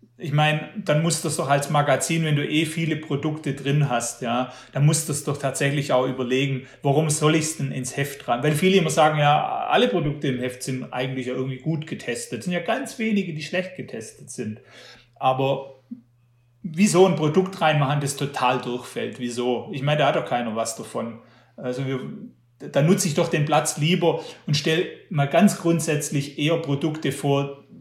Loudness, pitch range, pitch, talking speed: -23 LUFS, 130-160 Hz, 145 Hz, 190 wpm